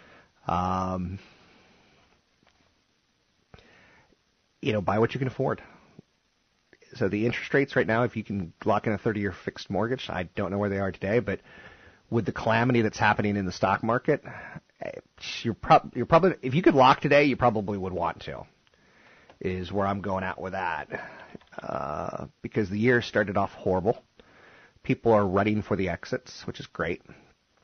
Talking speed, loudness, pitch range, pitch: 165 wpm, -26 LUFS, 95-120 Hz, 105 Hz